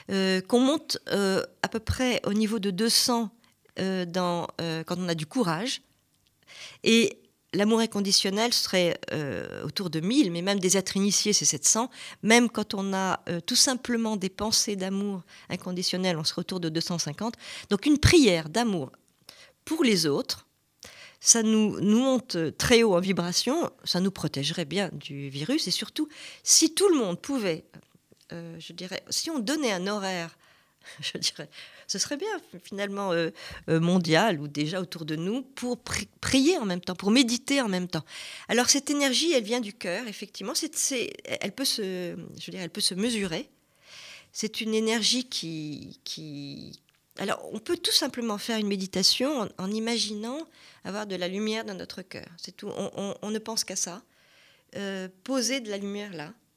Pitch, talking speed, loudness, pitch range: 200 Hz, 175 wpm, -26 LUFS, 175-235 Hz